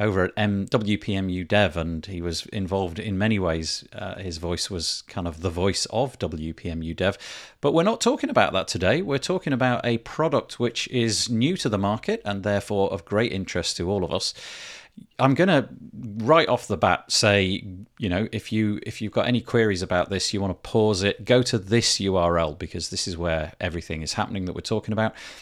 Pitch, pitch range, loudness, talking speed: 105 Hz, 90-115 Hz, -24 LUFS, 210 wpm